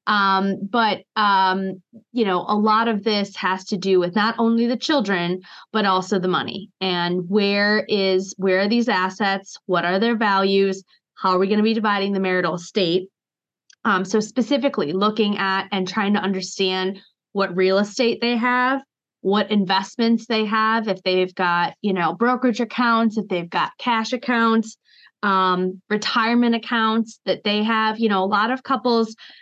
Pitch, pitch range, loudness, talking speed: 205 Hz, 190-225 Hz, -20 LUFS, 170 wpm